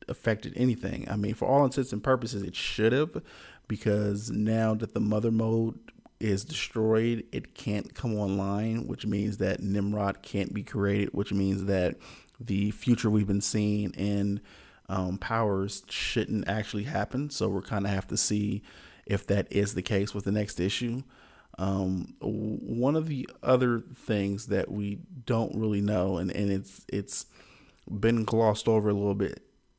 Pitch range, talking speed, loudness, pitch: 100-115 Hz, 165 wpm, -29 LUFS, 105 Hz